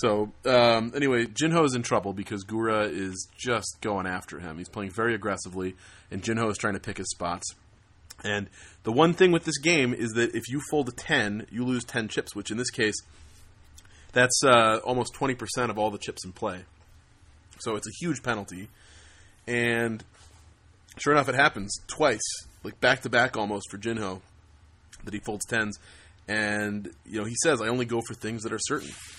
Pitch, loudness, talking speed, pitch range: 105 Hz, -27 LUFS, 195 wpm, 95-120 Hz